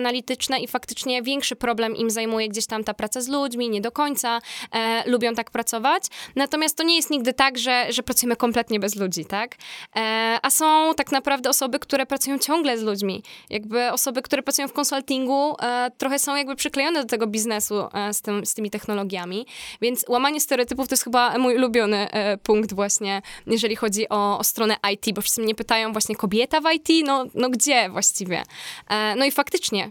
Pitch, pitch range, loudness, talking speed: 240 Hz, 215-275 Hz, -22 LUFS, 195 wpm